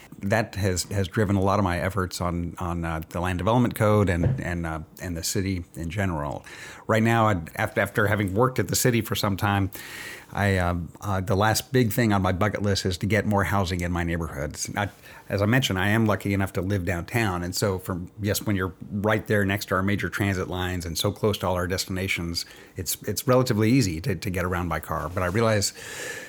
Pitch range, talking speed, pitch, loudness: 90-105 Hz, 230 wpm, 100 Hz, -25 LUFS